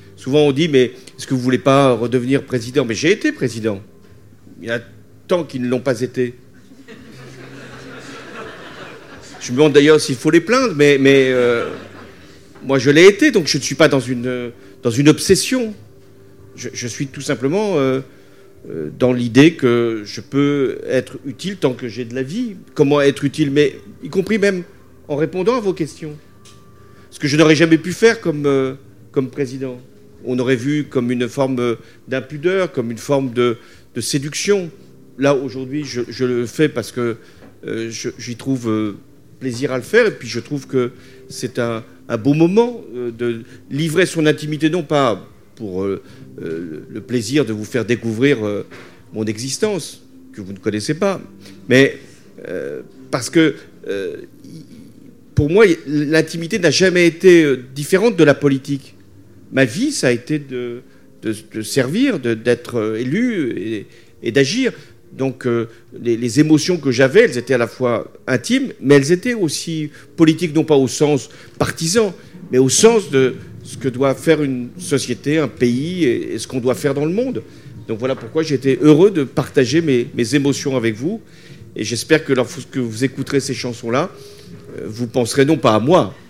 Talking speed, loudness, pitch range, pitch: 180 wpm, -17 LUFS, 120-155 Hz, 135 Hz